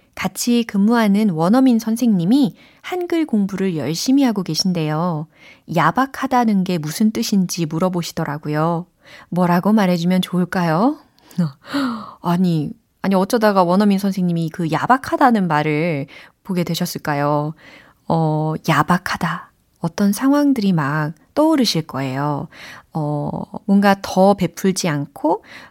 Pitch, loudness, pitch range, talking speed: 185 Hz, -18 LUFS, 160-215 Hz, 270 characters per minute